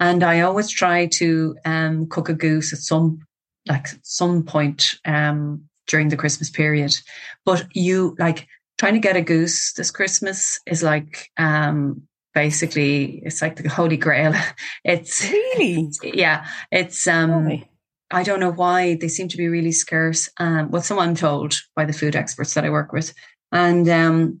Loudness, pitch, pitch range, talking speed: -19 LUFS, 160 Hz, 155-175 Hz, 170 wpm